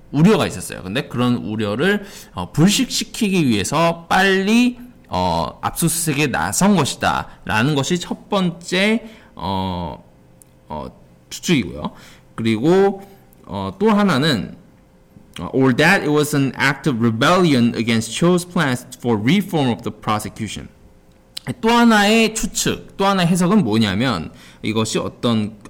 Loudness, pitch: -18 LUFS, 150 Hz